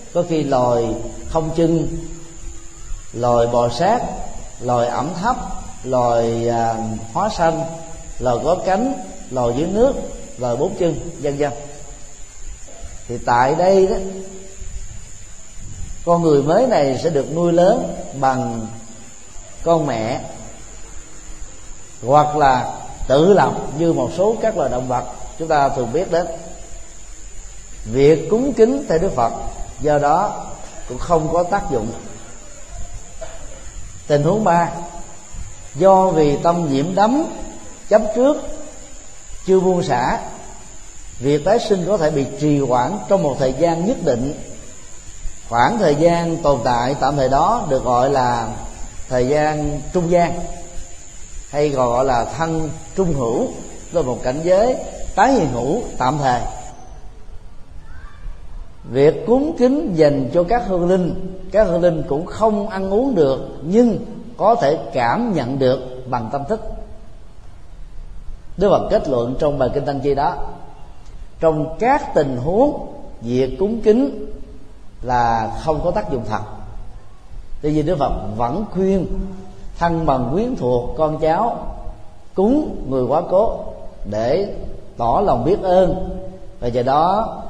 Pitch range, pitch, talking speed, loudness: 120-180 Hz, 145 Hz, 135 wpm, -18 LUFS